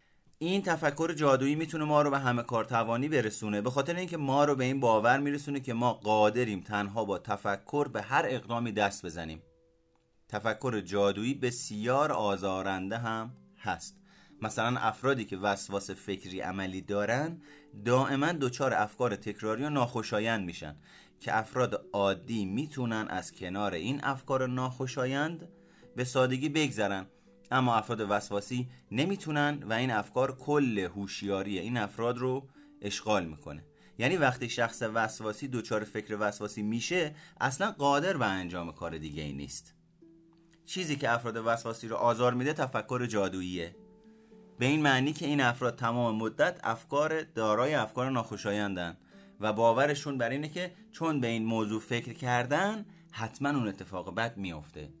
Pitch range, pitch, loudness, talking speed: 105-140 Hz, 120 Hz, -31 LUFS, 140 wpm